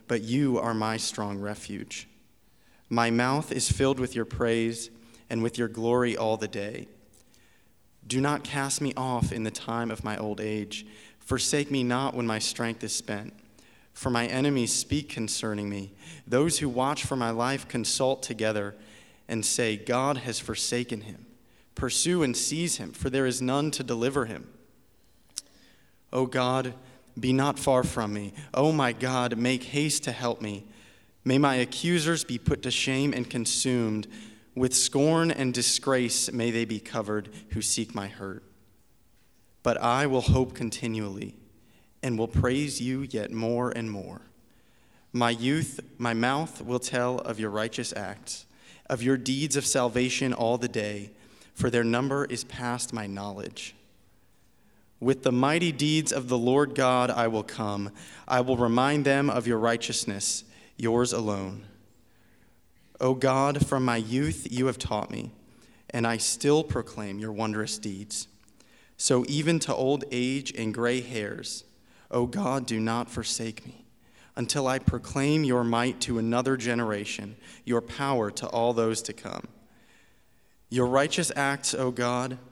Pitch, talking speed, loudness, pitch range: 120 Hz, 160 wpm, -28 LUFS, 110-130 Hz